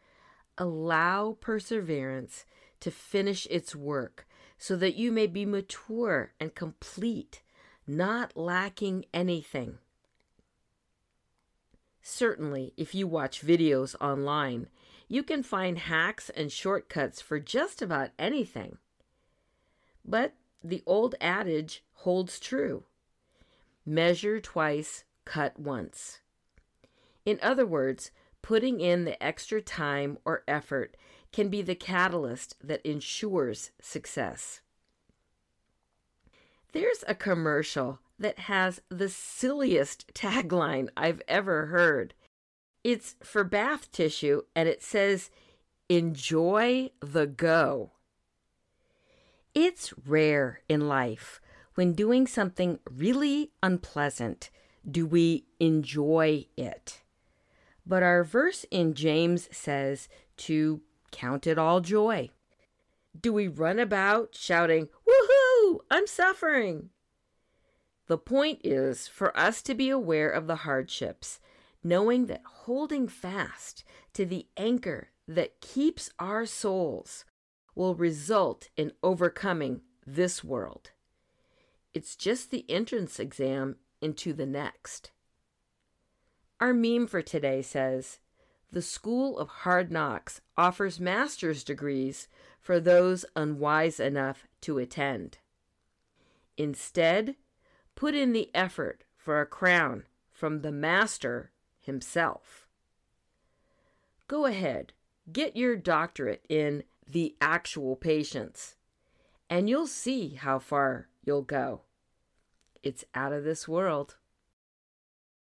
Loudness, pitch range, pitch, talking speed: -29 LUFS, 150-220 Hz, 175 Hz, 105 wpm